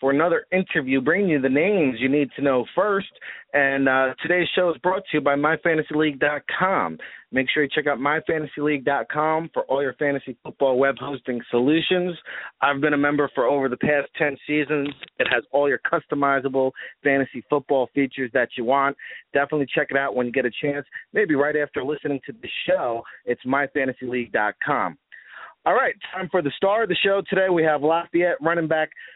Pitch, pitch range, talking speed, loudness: 145 Hz, 135-155 Hz, 185 wpm, -22 LUFS